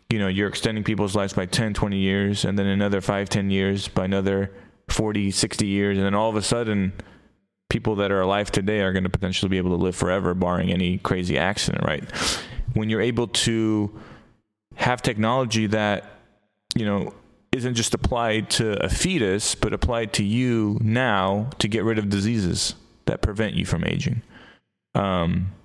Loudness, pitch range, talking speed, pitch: -23 LUFS, 95-110 Hz, 180 wpm, 100 Hz